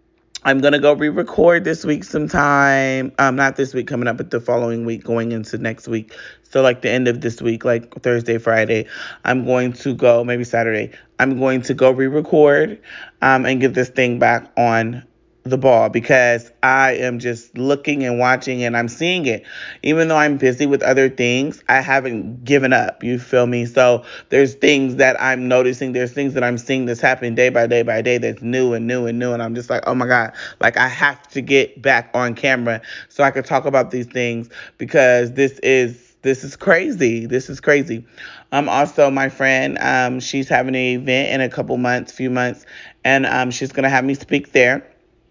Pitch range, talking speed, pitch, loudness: 120-135 Hz, 205 wpm, 130 Hz, -17 LUFS